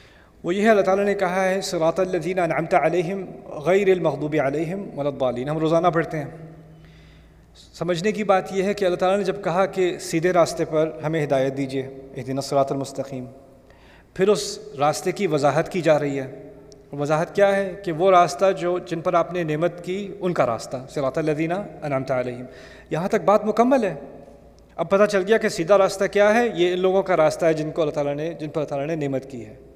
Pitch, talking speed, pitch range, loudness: 165 Hz, 210 wpm, 140-190 Hz, -22 LUFS